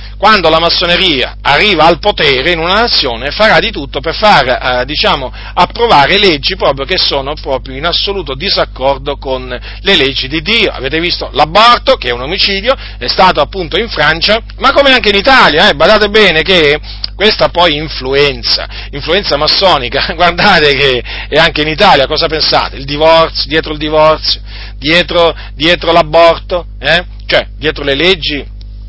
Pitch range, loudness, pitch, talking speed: 135-185 Hz, -9 LUFS, 160 Hz, 160 wpm